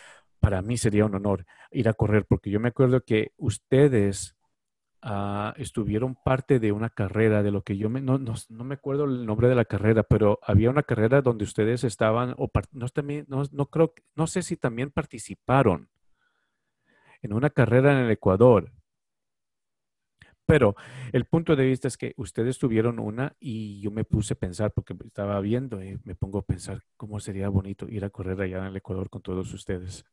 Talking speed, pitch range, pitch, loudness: 190 wpm, 100-130 Hz, 115 Hz, -25 LUFS